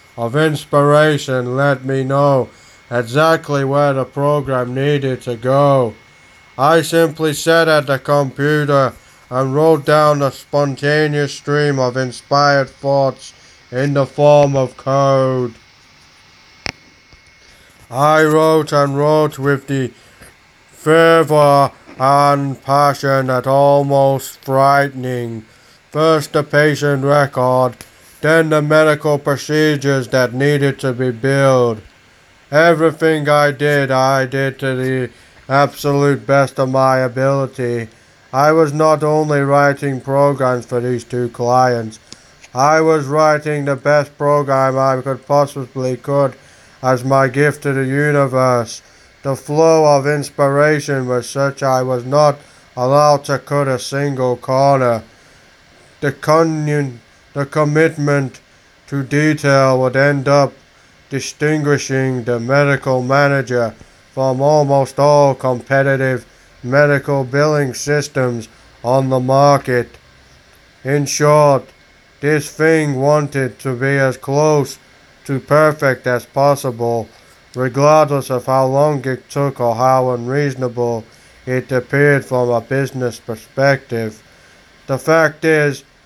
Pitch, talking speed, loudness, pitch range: 140 Hz, 115 wpm, -15 LUFS, 130-145 Hz